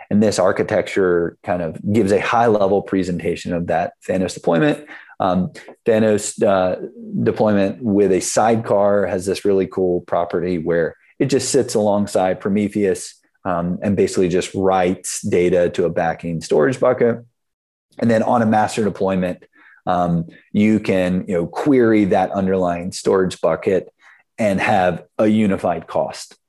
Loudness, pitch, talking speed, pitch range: -18 LUFS, 95 Hz, 145 wpm, 90-105 Hz